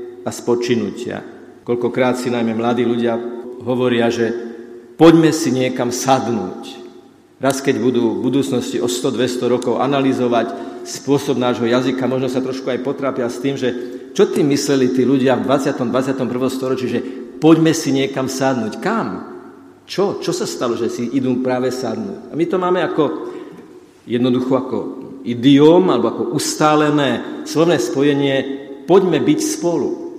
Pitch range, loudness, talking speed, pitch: 125-140 Hz, -17 LUFS, 145 wpm, 130 Hz